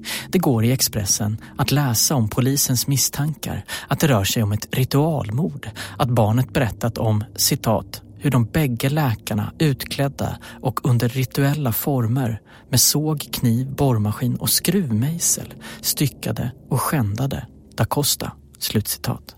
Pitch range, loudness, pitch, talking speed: 110-140 Hz, -20 LUFS, 130 Hz, 130 wpm